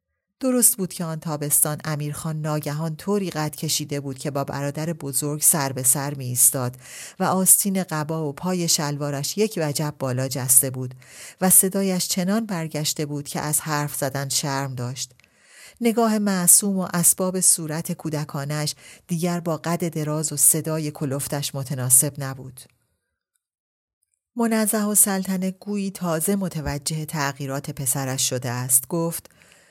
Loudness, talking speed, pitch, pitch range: -21 LUFS, 135 wpm, 155 Hz, 140-180 Hz